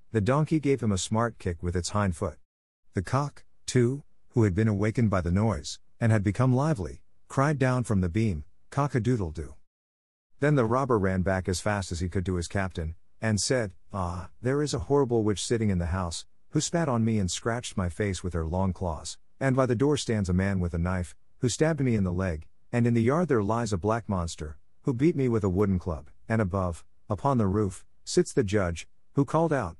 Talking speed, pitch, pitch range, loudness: 225 wpm, 105 Hz, 90-125 Hz, -28 LUFS